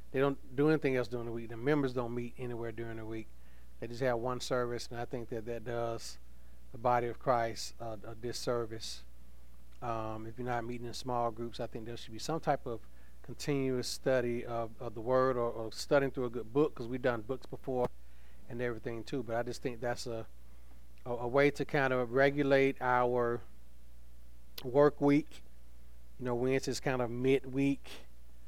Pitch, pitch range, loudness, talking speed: 120 Hz, 110-130 Hz, -34 LUFS, 195 wpm